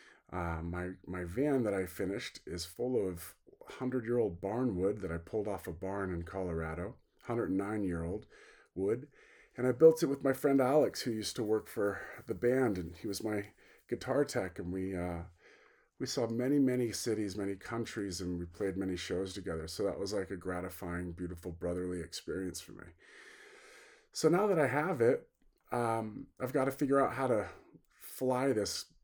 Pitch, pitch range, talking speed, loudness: 100 Hz, 90-125 Hz, 190 wpm, -35 LUFS